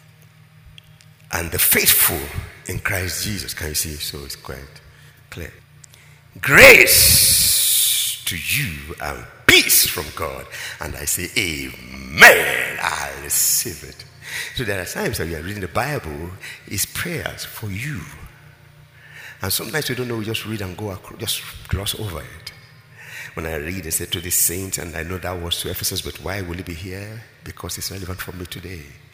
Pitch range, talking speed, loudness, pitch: 85-115 Hz, 175 wpm, -16 LUFS, 95 Hz